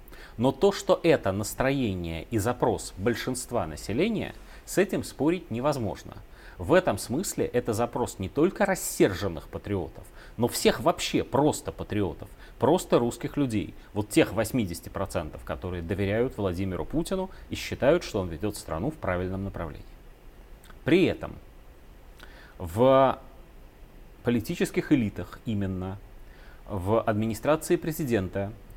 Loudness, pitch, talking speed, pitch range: -27 LUFS, 105 Hz, 115 wpm, 95-130 Hz